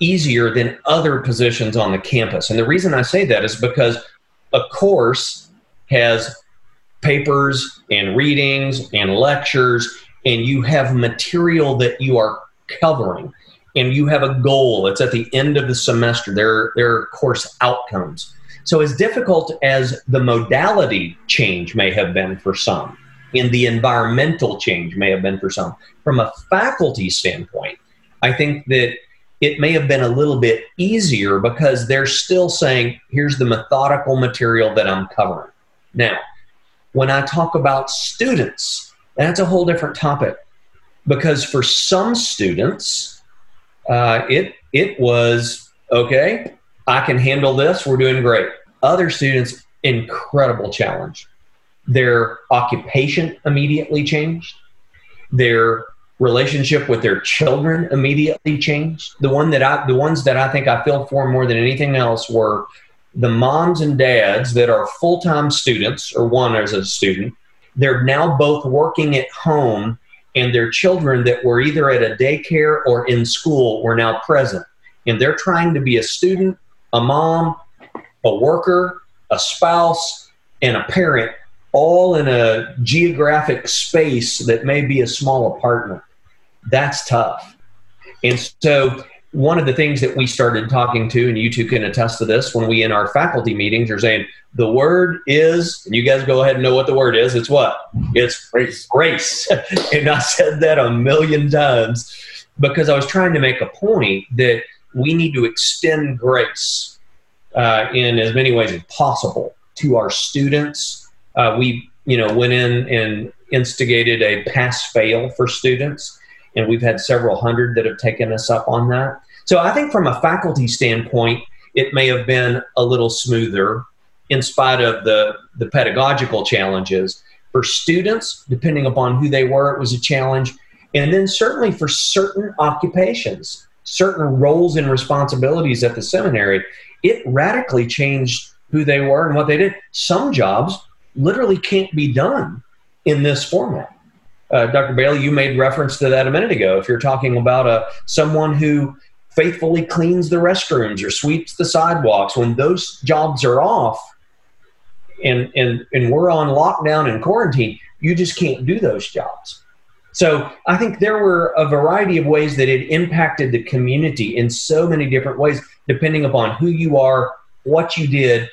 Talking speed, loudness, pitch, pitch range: 160 wpm, -16 LUFS, 135 Hz, 120-150 Hz